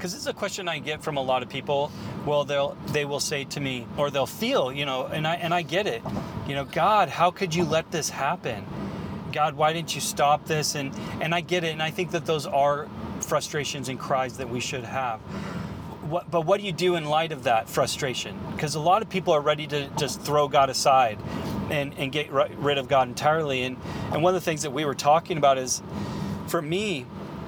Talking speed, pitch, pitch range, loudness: 235 wpm, 150 Hz, 140-170 Hz, -26 LUFS